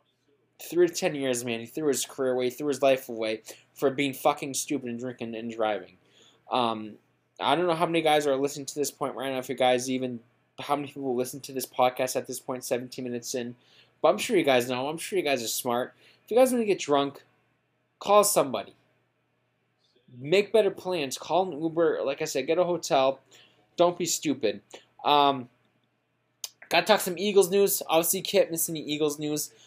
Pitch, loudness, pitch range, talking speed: 140 Hz, -27 LUFS, 125-165 Hz, 210 wpm